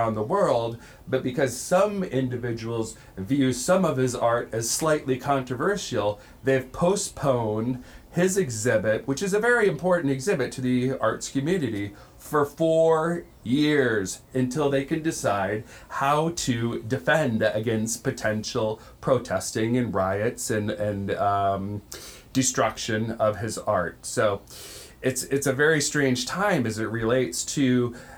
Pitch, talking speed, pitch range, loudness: 130 Hz, 130 wpm, 110-145 Hz, -25 LUFS